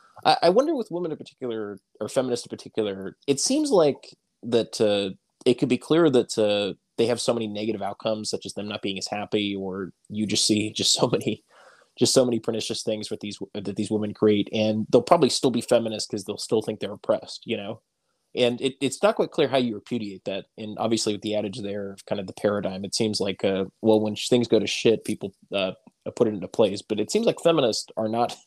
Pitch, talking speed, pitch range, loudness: 110 Hz, 235 wpm, 100-115 Hz, -25 LUFS